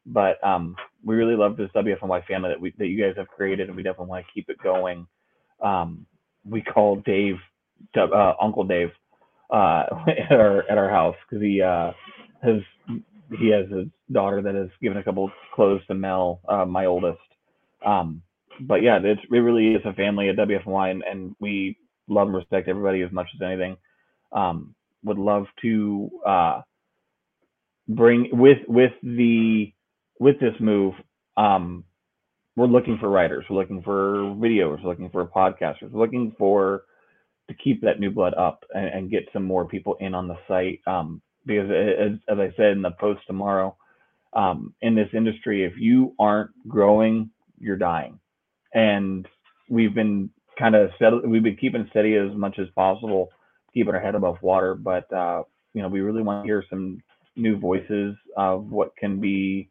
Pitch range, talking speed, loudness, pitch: 95-110 Hz, 180 wpm, -22 LUFS, 100 Hz